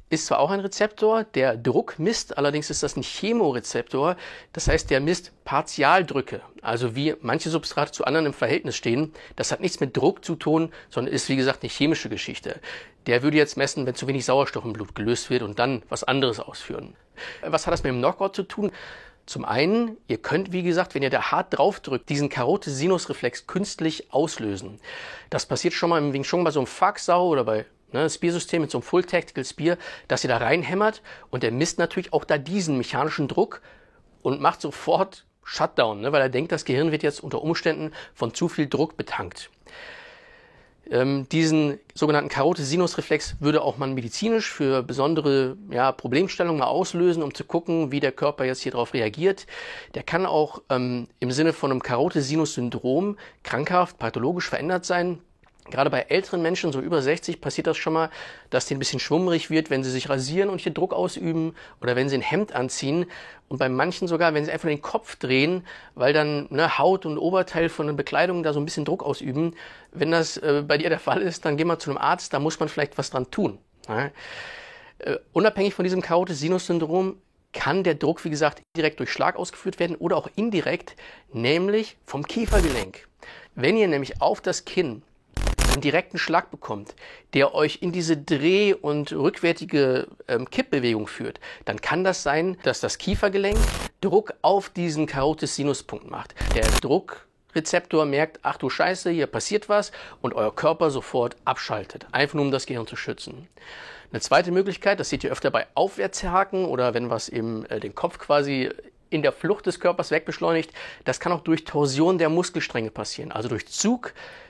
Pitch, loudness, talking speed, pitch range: 160 Hz, -24 LUFS, 185 wpm, 140-180 Hz